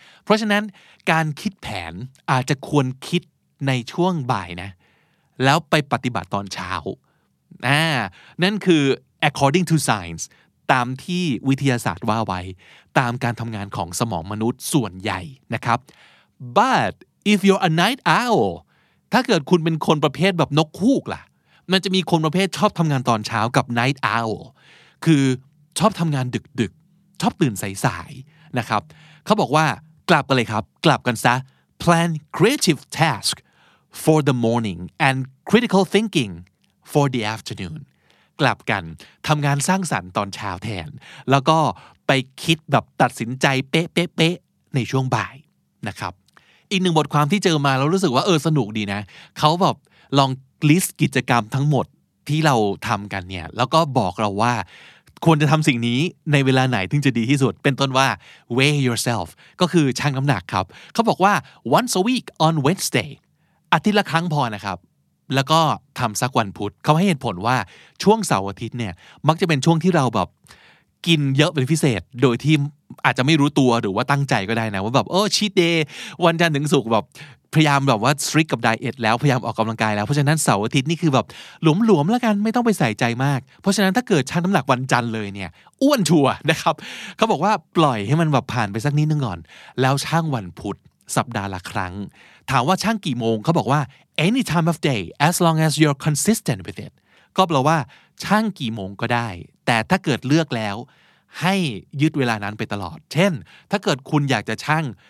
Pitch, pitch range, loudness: 140 Hz, 120-165 Hz, -20 LUFS